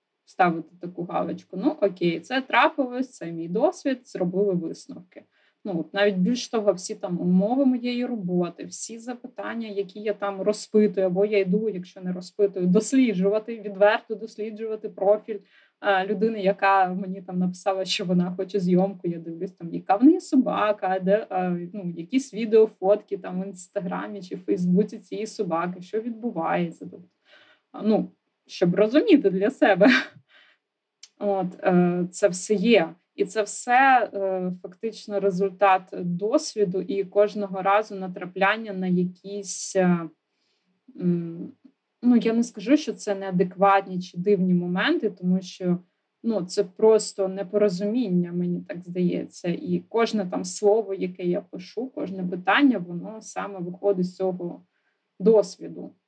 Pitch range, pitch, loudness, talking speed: 185-215 Hz, 200 Hz, -24 LUFS, 135 wpm